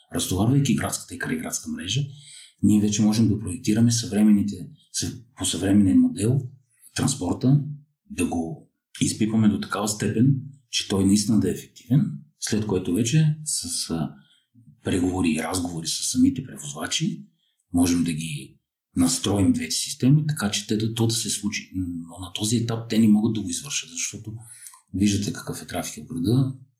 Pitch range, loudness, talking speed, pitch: 100-140 Hz, -23 LUFS, 150 wpm, 110 Hz